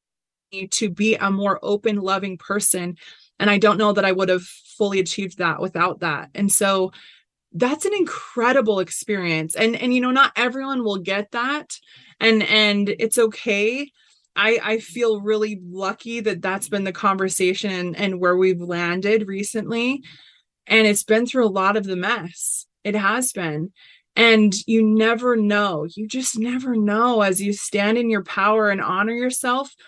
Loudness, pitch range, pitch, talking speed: -20 LUFS, 190-230 Hz, 210 Hz, 170 wpm